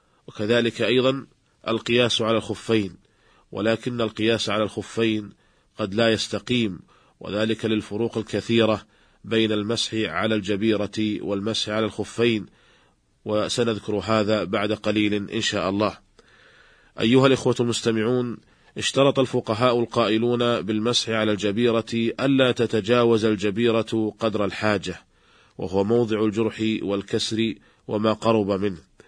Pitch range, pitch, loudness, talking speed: 105-115 Hz, 110 Hz, -23 LUFS, 105 wpm